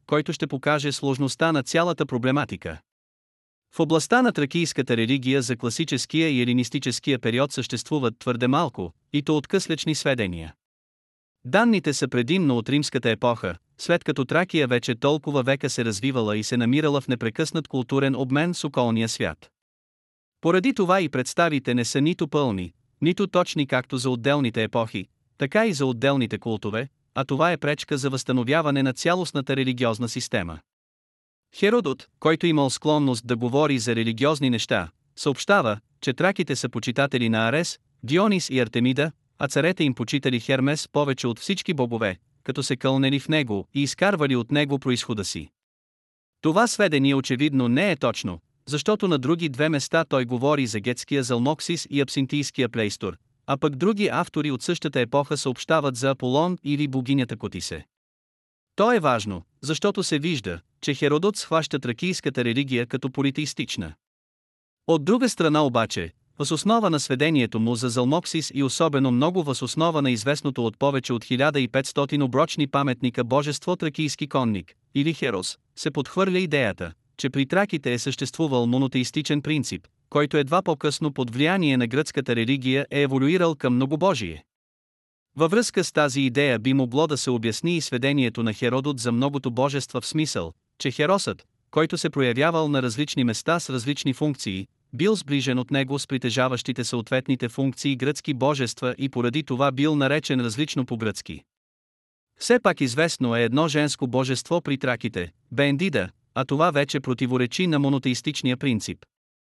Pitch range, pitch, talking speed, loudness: 125-155 Hz, 135 Hz, 150 wpm, -24 LUFS